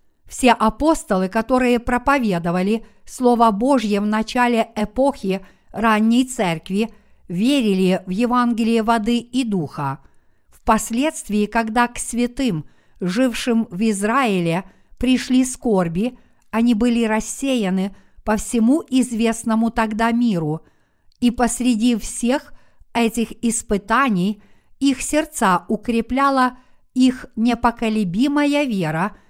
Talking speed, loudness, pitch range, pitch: 90 wpm, -19 LUFS, 210-250 Hz, 230 Hz